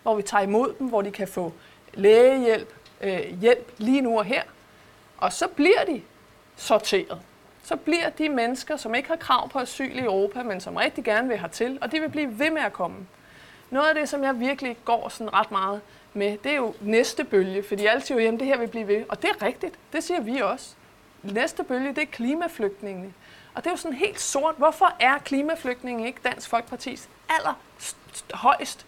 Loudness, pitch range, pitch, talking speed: -24 LUFS, 215-300 Hz, 250 Hz, 220 wpm